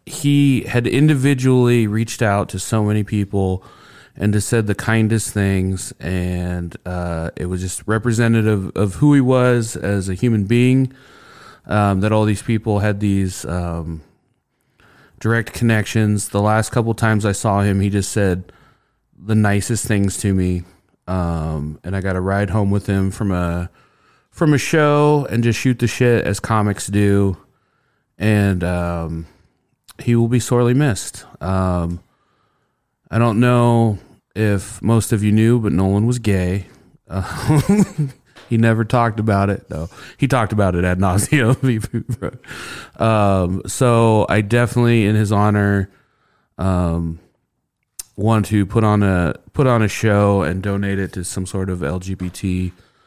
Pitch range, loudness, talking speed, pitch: 95-115 Hz, -18 LUFS, 155 wpm, 105 Hz